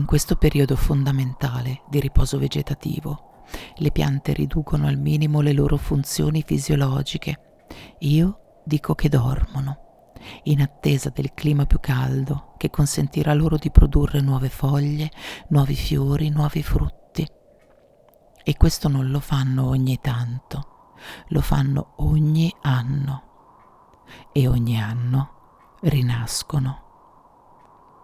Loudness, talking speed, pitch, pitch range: -22 LUFS, 110 wpm, 145 Hz, 135-155 Hz